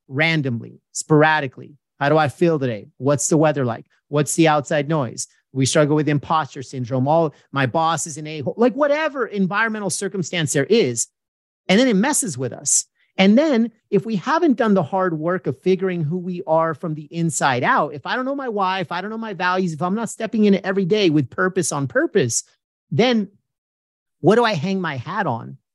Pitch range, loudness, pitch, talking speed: 145-195 Hz, -20 LUFS, 165 Hz, 205 wpm